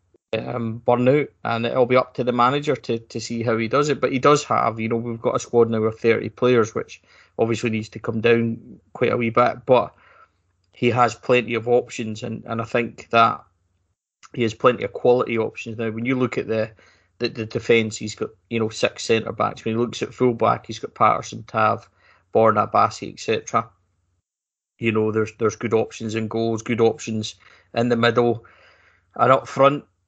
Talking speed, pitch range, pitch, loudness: 205 wpm, 110-120 Hz, 115 Hz, -21 LUFS